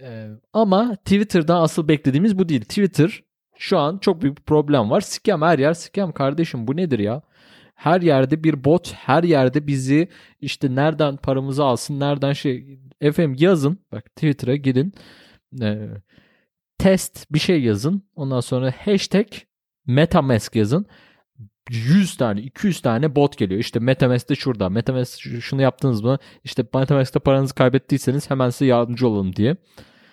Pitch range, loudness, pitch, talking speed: 125-165 Hz, -20 LUFS, 140 Hz, 145 wpm